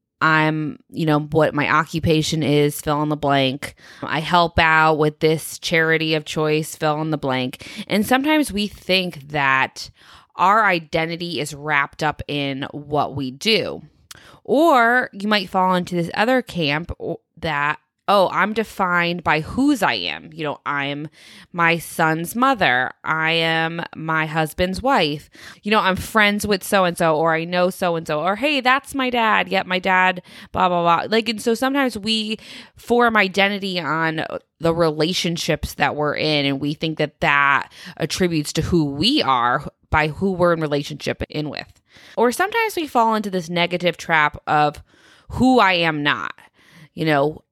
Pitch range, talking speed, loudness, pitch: 150-195 Hz, 170 wpm, -19 LUFS, 165 Hz